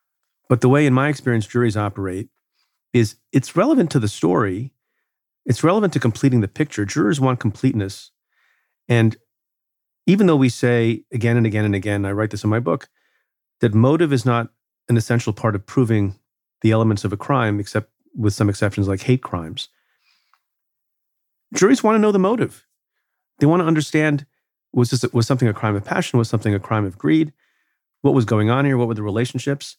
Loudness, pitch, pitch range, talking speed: -19 LUFS, 120 Hz, 110-140 Hz, 190 wpm